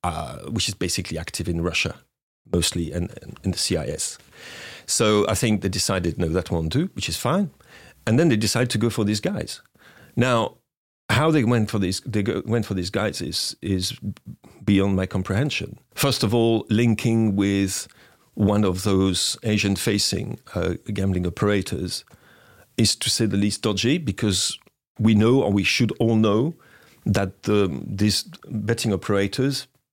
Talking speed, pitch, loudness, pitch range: 165 wpm, 105 Hz, -23 LUFS, 95-115 Hz